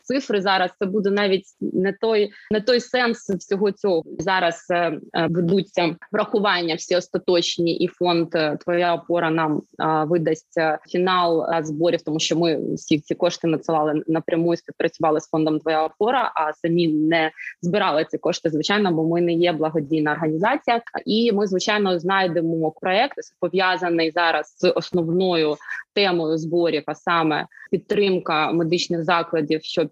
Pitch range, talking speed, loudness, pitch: 160-190 Hz, 140 wpm, -21 LUFS, 170 Hz